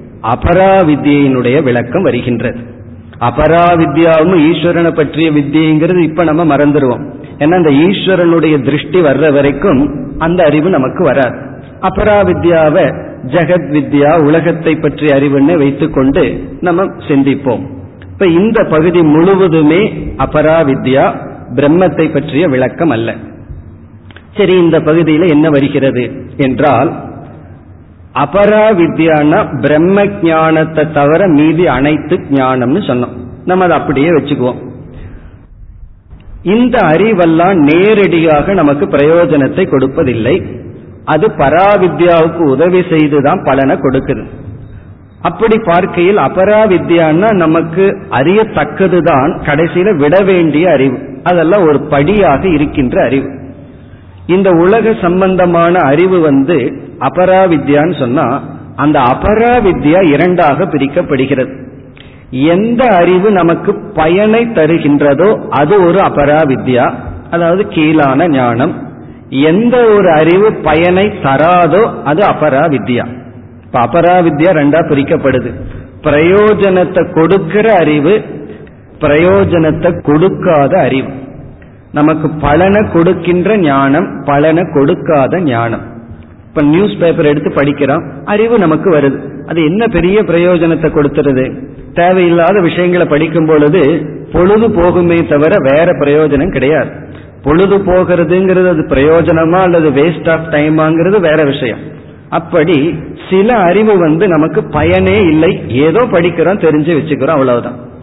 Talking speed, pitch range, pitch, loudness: 95 wpm, 140-175 Hz, 155 Hz, -9 LUFS